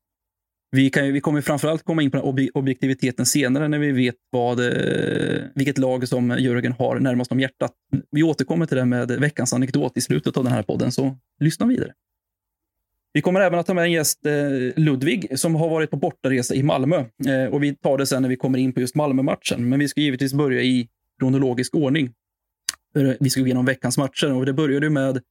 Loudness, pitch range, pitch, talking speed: -21 LUFS, 125-150 Hz, 135 Hz, 200 wpm